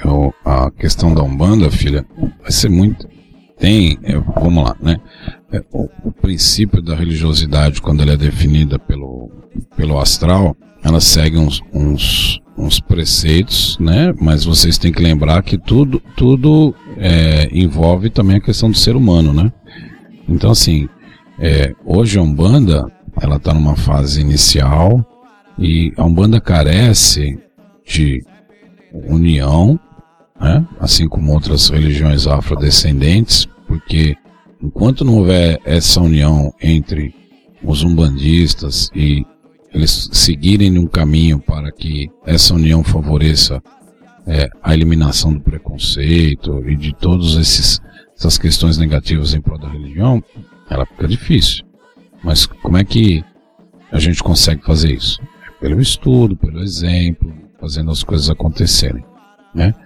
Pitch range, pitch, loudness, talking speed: 75-95 Hz, 80 Hz, -12 LUFS, 130 wpm